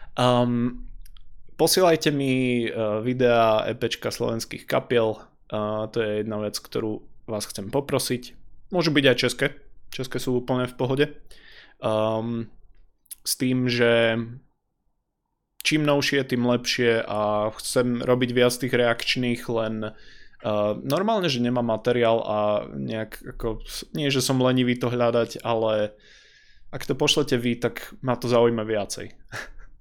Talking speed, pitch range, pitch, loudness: 130 wpm, 110-130 Hz, 120 Hz, -24 LUFS